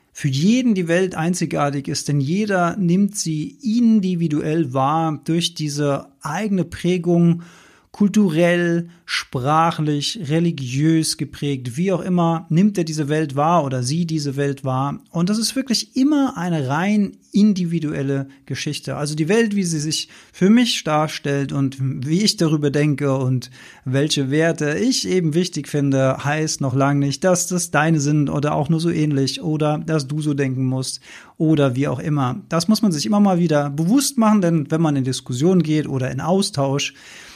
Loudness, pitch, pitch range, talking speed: -19 LUFS, 155 Hz, 140-180 Hz, 165 wpm